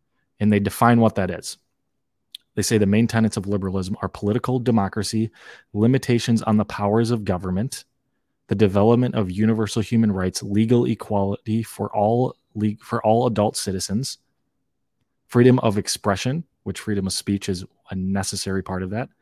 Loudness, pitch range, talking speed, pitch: -22 LUFS, 100-115 Hz, 155 wpm, 105 Hz